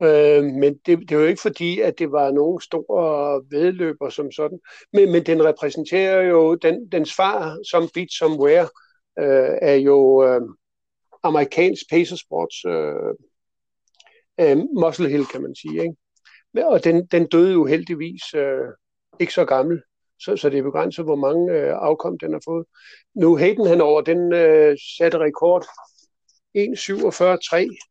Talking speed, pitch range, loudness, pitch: 150 wpm, 150-180 Hz, -19 LUFS, 165 Hz